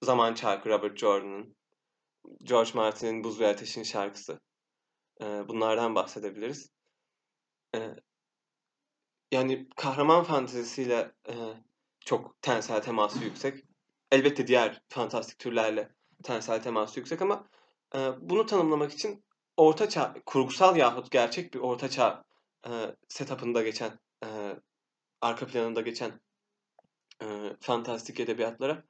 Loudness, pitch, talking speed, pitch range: -29 LUFS, 120 Hz, 95 wpm, 110-135 Hz